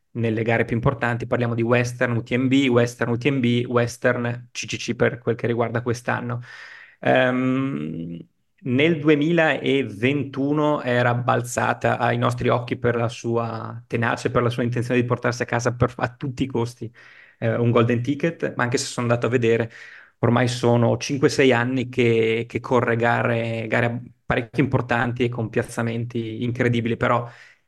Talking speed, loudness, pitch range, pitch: 150 wpm, -22 LUFS, 115-125 Hz, 120 Hz